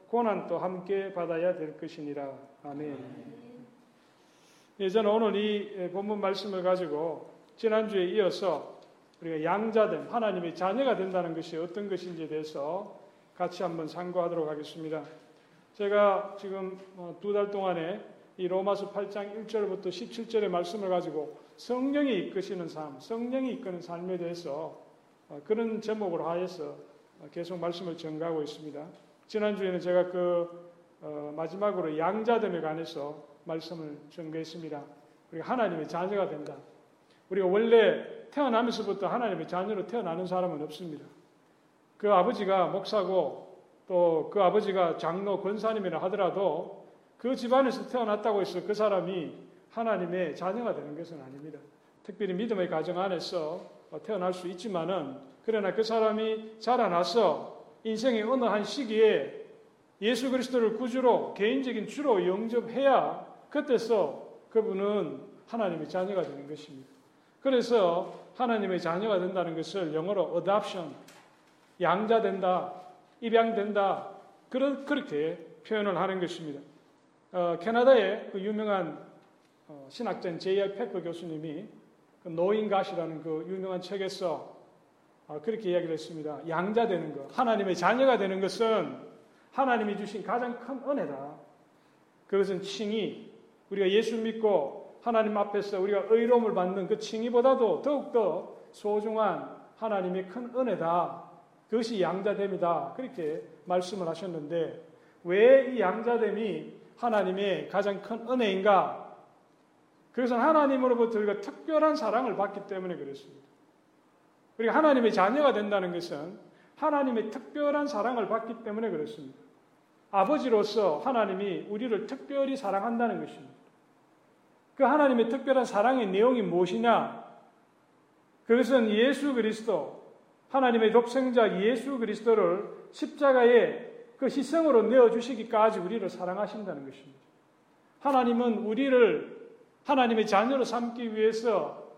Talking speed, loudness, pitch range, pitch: 310 characters per minute, -29 LUFS, 175-230 Hz, 200 Hz